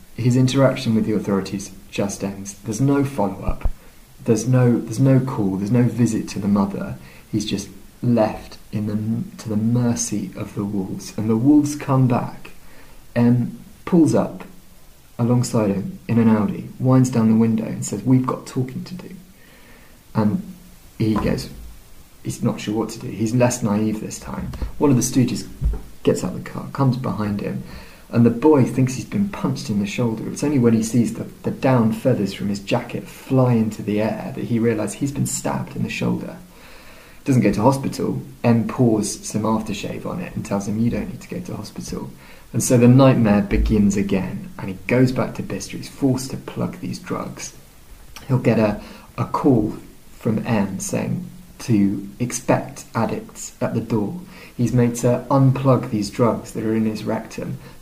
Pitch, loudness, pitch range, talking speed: 115 Hz, -21 LUFS, 105-125 Hz, 185 wpm